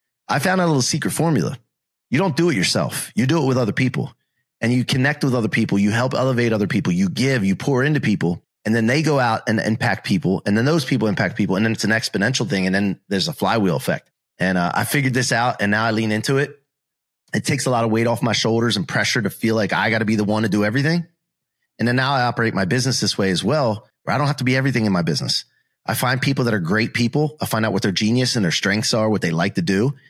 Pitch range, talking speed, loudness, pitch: 110-140 Hz, 275 wpm, -19 LUFS, 120 Hz